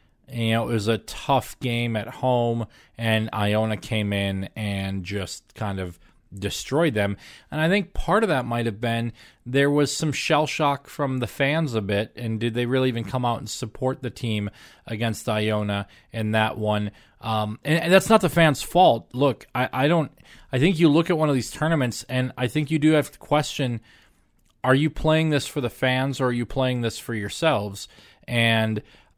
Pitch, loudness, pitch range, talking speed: 120 Hz, -23 LUFS, 110-145 Hz, 200 wpm